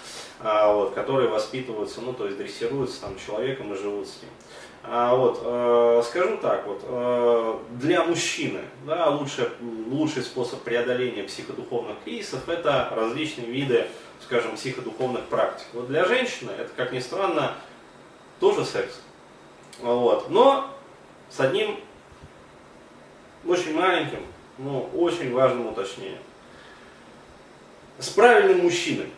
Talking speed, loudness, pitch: 120 wpm, -24 LUFS, 130 Hz